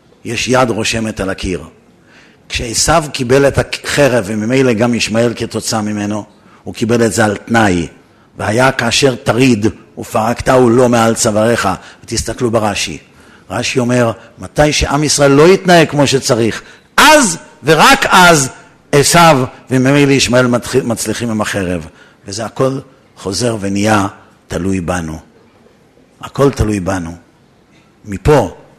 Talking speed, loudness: 120 wpm, -12 LUFS